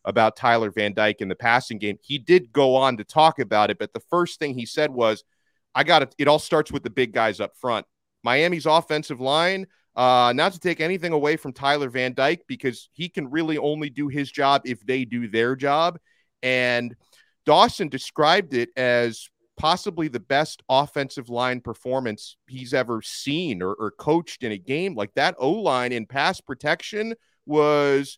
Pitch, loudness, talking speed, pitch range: 135 Hz, -22 LUFS, 190 wpm, 120-155 Hz